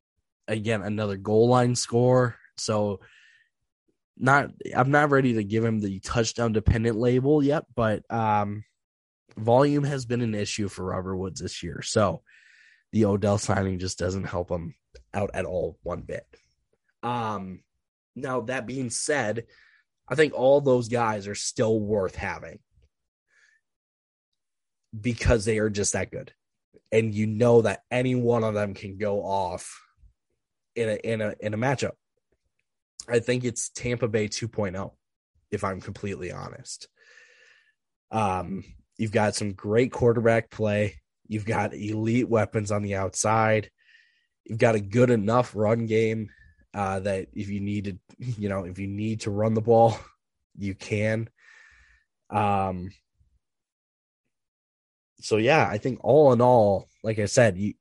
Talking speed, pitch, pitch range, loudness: 145 wpm, 110 Hz, 100-120 Hz, -25 LUFS